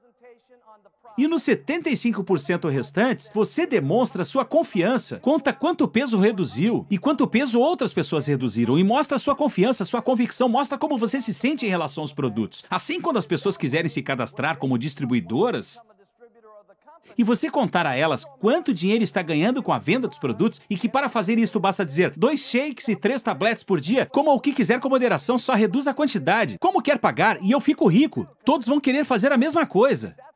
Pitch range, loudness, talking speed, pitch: 195-275 Hz, -22 LUFS, 185 wpm, 235 Hz